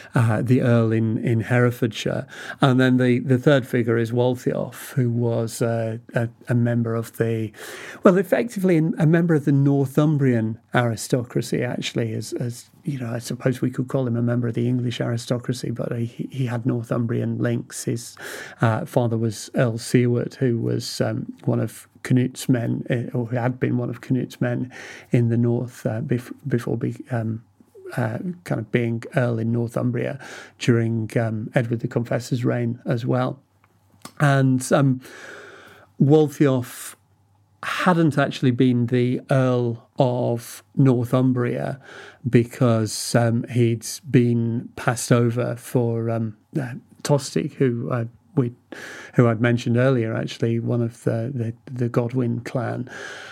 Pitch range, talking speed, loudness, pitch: 115-130 Hz, 150 wpm, -22 LUFS, 120 Hz